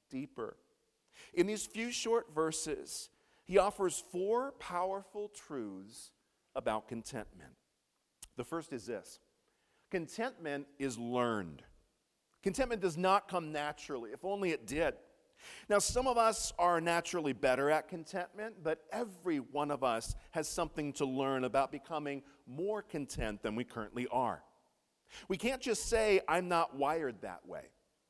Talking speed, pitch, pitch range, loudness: 135 wpm, 170 Hz, 135-210 Hz, -36 LUFS